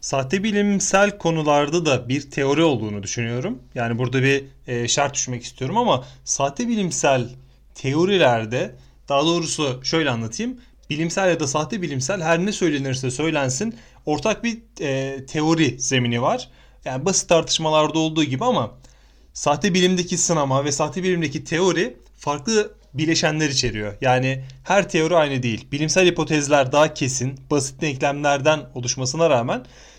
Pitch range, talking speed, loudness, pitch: 130-170 Hz, 135 wpm, -21 LUFS, 150 Hz